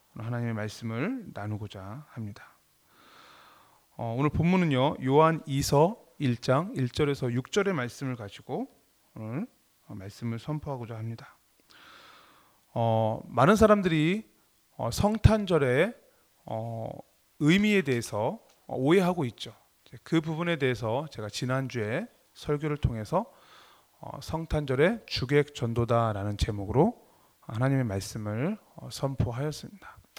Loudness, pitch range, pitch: -28 LUFS, 115-160 Hz, 130 Hz